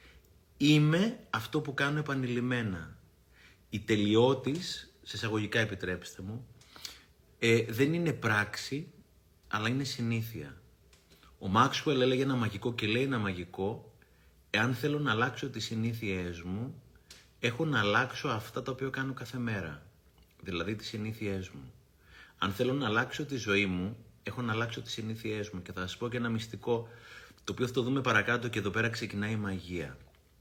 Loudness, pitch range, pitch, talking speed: -32 LUFS, 100-130 Hz, 115 Hz, 155 wpm